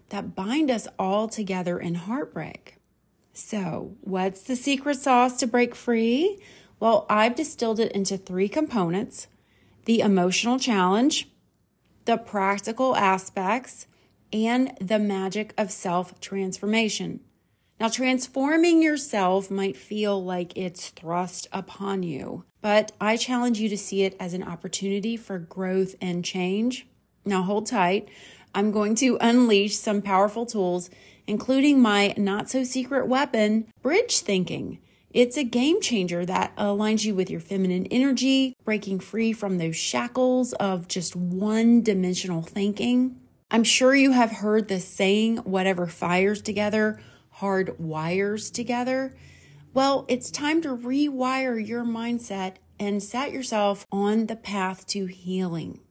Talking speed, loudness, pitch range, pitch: 135 wpm, -24 LUFS, 190-245 Hz, 210 Hz